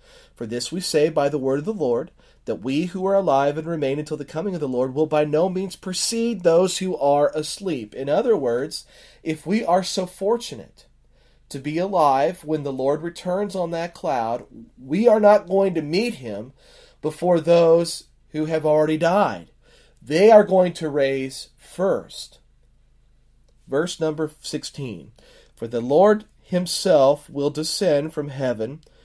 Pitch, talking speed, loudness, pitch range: 165 Hz, 165 wpm, -21 LUFS, 150-190 Hz